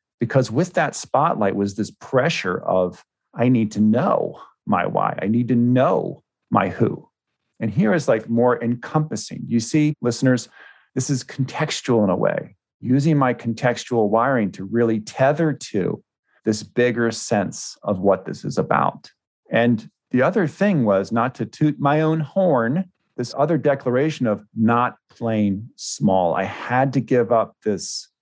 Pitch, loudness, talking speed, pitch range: 125 Hz, -21 LUFS, 160 wpm, 115-140 Hz